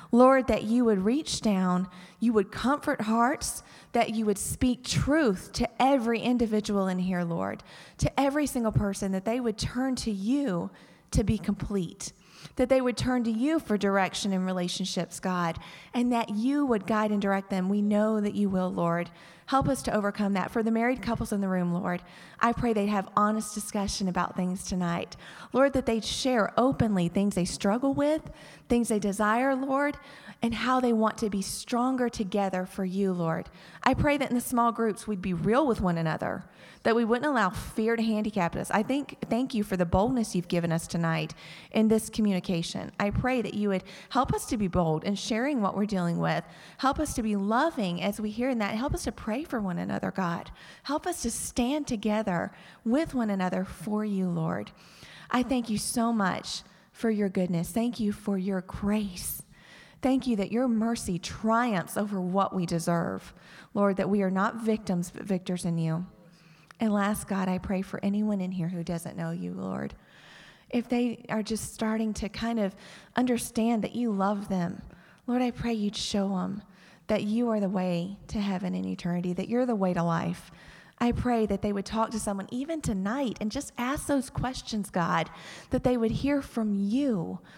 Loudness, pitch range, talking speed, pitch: -28 LUFS, 185-235 Hz, 195 wpm, 210 Hz